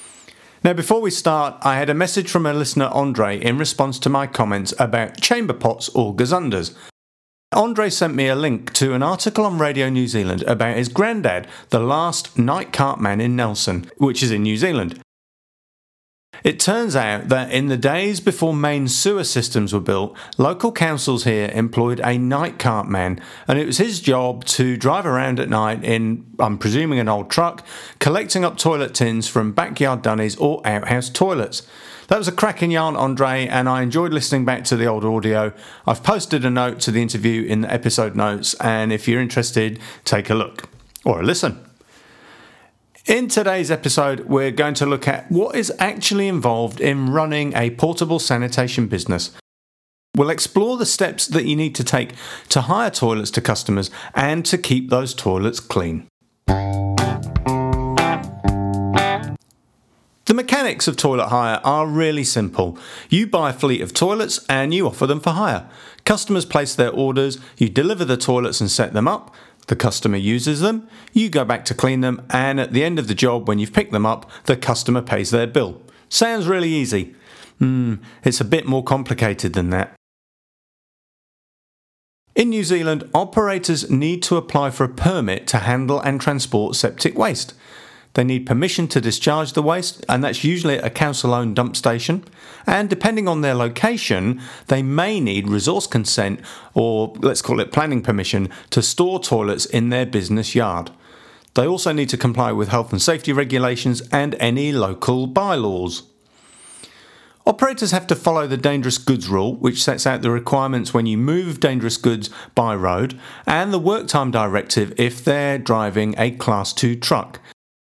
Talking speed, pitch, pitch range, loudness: 175 wpm, 130 Hz, 115-155 Hz, -19 LUFS